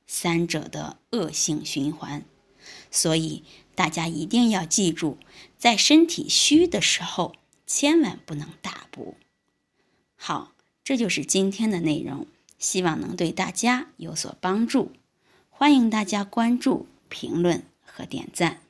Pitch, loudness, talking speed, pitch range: 190 Hz, -23 LUFS, 190 characters per minute, 165-240 Hz